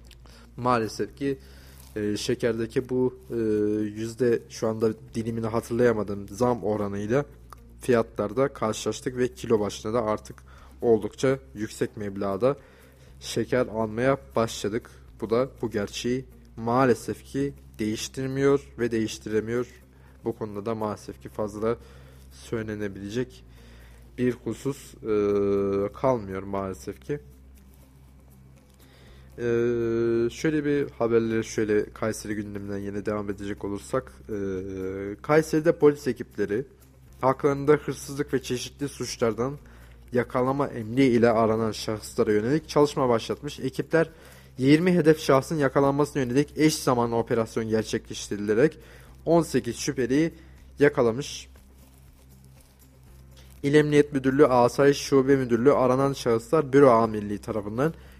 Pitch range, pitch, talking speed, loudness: 100-130 Hz, 115 Hz, 100 wpm, -26 LUFS